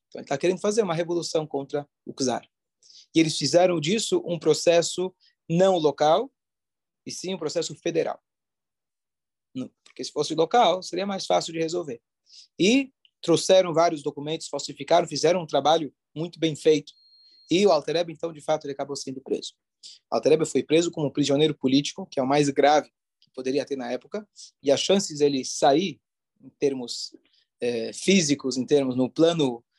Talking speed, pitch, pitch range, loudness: 165 wpm, 155 Hz, 140-175 Hz, -24 LUFS